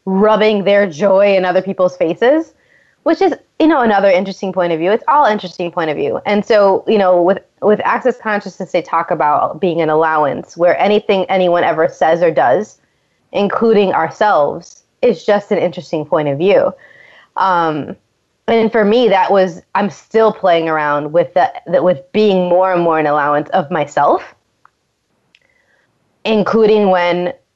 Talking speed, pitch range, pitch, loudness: 165 wpm, 175-215 Hz, 190 Hz, -14 LUFS